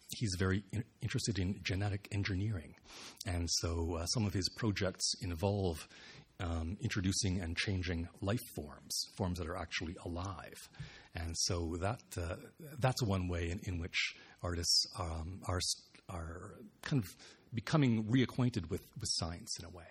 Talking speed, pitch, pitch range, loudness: 150 wpm, 95 Hz, 85-110 Hz, -37 LUFS